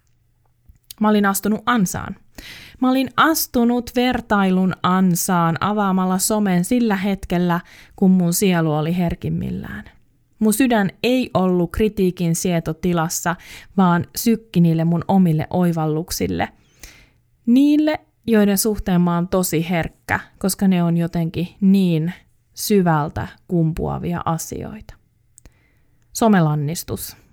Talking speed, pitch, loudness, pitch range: 100 wpm, 180 Hz, -19 LUFS, 165-210 Hz